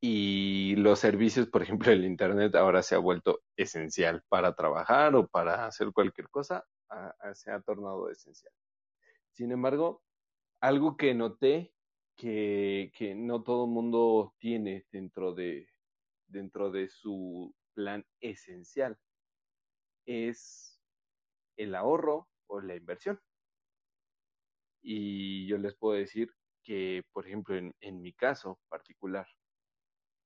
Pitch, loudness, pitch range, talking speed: 105 Hz, -31 LUFS, 95-120 Hz, 125 wpm